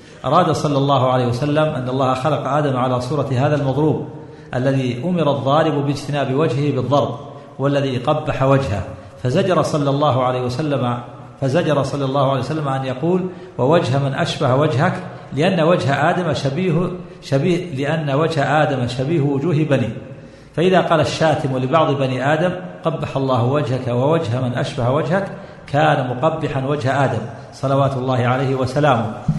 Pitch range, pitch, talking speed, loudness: 130-155 Hz, 140 Hz, 145 wpm, -18 LUFS